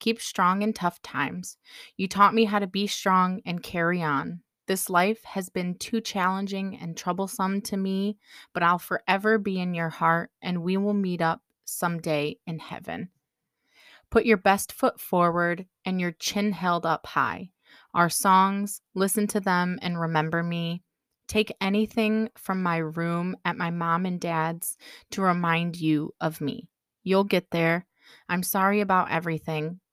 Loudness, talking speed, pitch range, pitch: -26 LUFS, 160 wpm, 170-200 Hz, 180 Hz